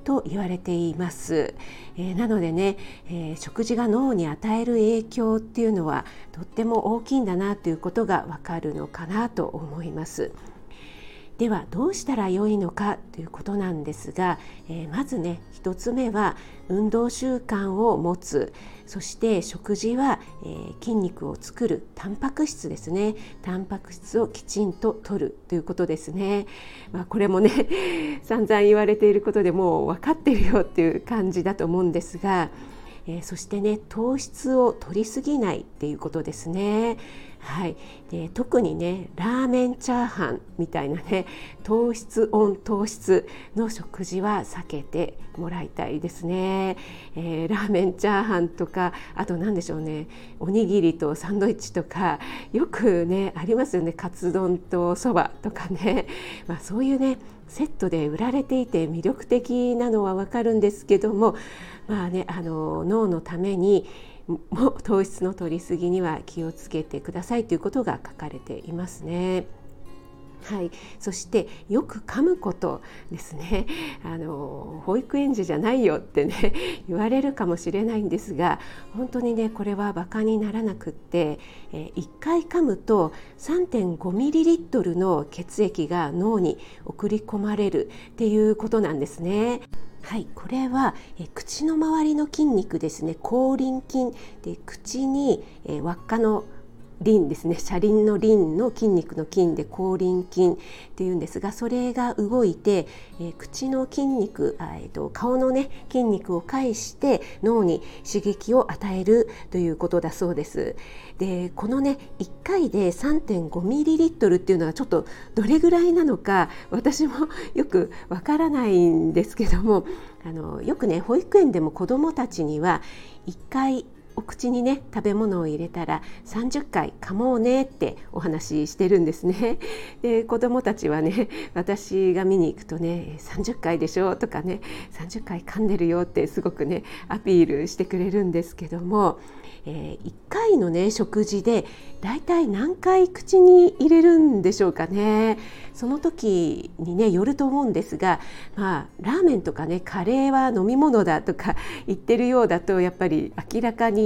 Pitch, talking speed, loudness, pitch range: 200 Hz, 310 characters per minute, -24 LUFS, 175-235 Hz